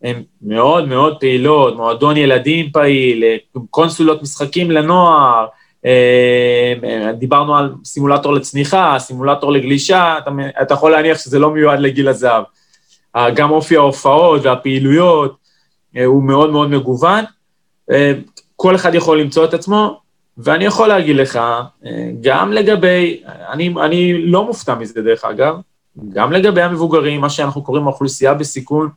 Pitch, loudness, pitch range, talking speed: 145 Hz, -12 LUFS, 130-165 Hz, 125 wpm